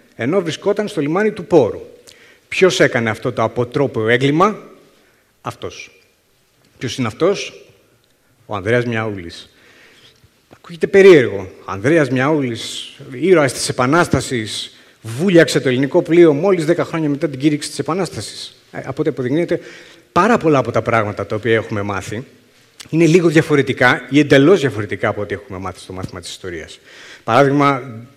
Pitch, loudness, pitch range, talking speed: 140 Hz, -15 LUFS, 120-165 Hz, 140 wpm